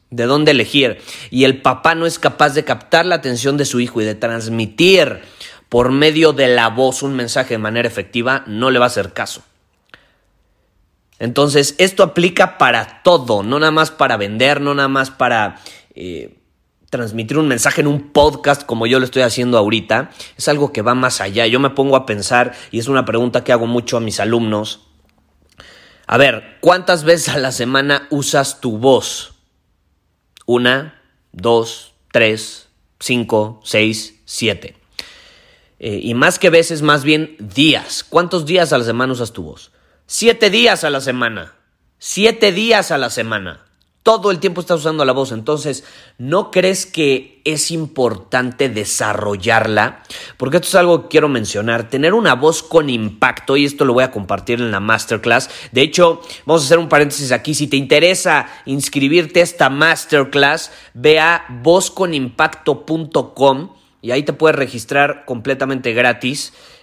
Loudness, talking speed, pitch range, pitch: -14 LUFS, 165 wpm, 120-155 Hz, 135 Hz